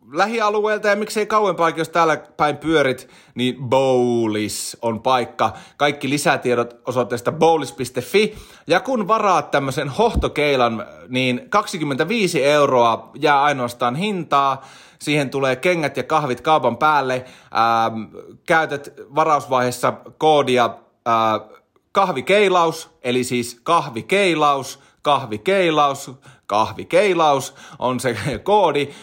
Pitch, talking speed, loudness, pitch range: 140 Hz, 100 wpm, -19 LUFS, 125-165 Hz